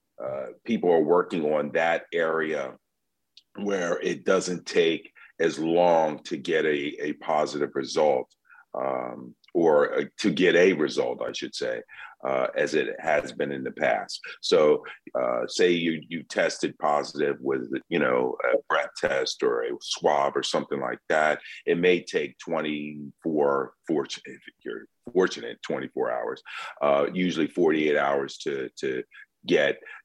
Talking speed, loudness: 145 wpm, -26 LUFS